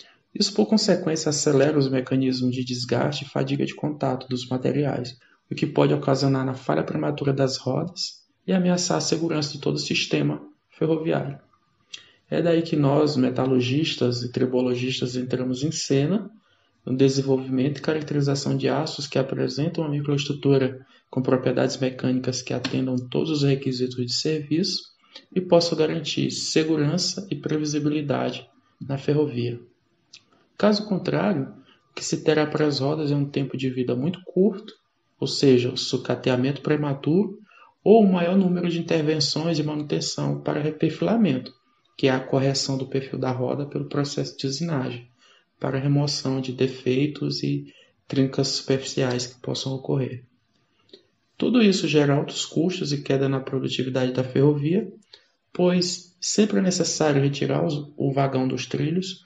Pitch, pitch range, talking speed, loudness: 140 Hz, 130-160 Hz, 145 wpm, -24 LUFS